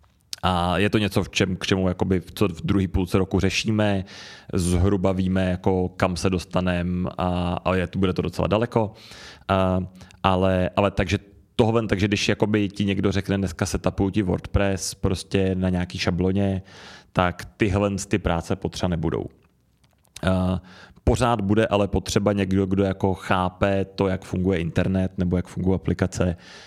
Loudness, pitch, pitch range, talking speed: -23 LUFS, 95 Hz, 90-100 Hz, 160 wpm